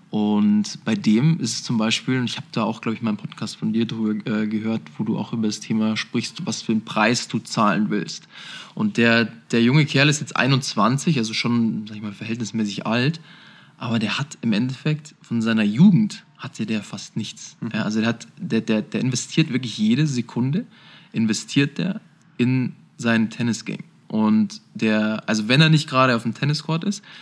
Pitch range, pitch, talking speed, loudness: 115-160 Hz, 125 Hz, 190 wpm, -22 LUFS